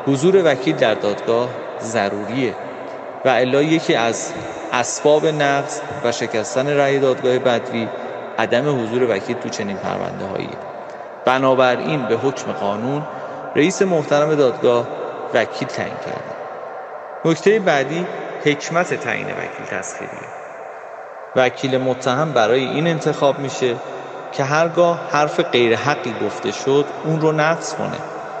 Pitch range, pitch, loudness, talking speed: 125-155 Hz, 140 Hz, -19 LUFS, 120 wpm